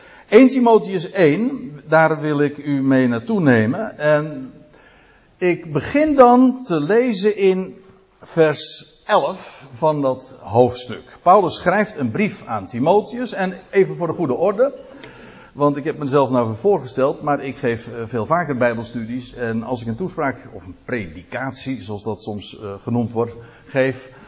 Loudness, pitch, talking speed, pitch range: -18 LUFS, 140 Hz, 150 wpm, 120-180 Hz